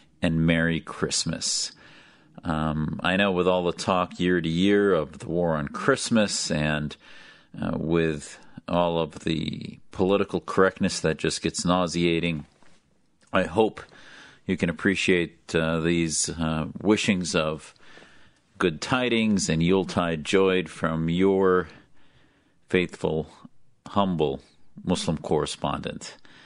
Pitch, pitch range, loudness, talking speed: 85 Hz, 80-95 Hz, -25 LUFS, 115 wpm